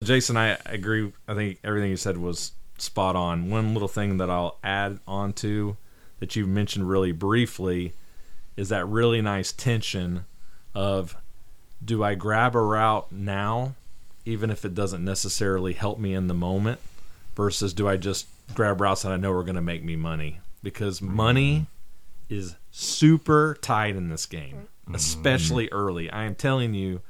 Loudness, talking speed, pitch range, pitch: -26 LUFS, 165 wpm, 90-110 Hz, 100 Hz